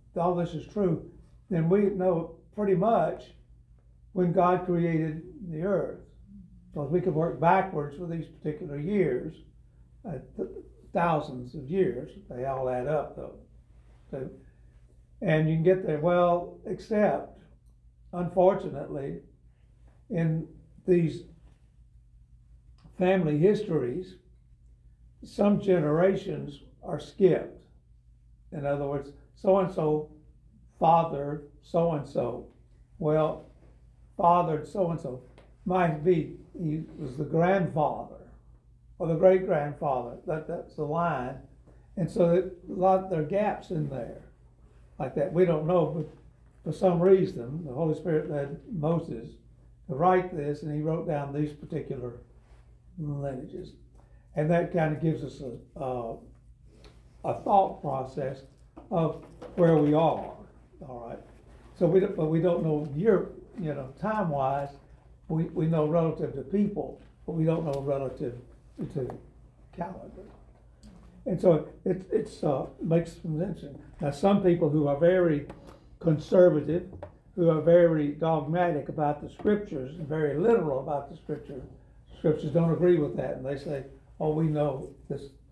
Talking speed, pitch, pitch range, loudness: 140 wpm, 160 Hz, 145-175 Hz, -28 LUFS